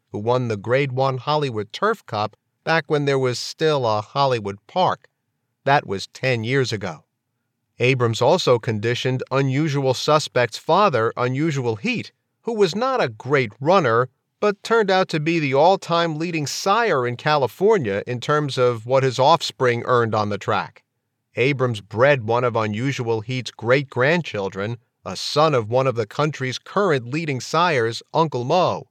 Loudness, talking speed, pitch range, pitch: -20 LUFS, 160 wpm, 120-150 Hz, 130 Hz